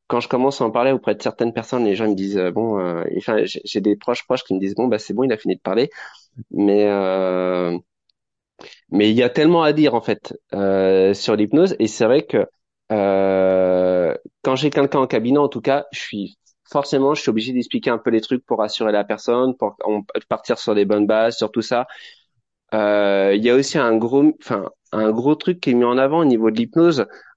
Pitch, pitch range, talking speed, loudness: 110 Hz, 100-130 Hz, 230 wpm, -19 LUFS